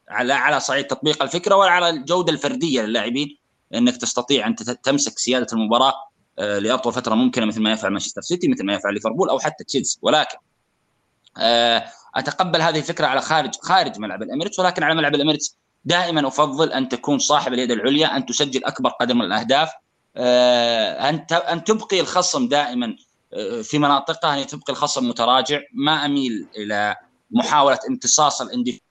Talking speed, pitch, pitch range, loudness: 150 wpm, 140 Hz, 125-160 Hz, -19 LUFS